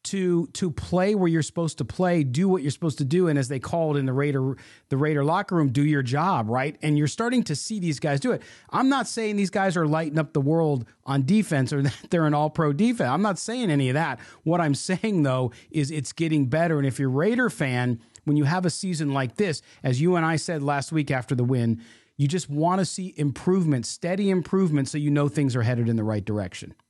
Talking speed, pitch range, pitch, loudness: 250 wpm, 135-175 Hz, 150 Hz, -24 LUFS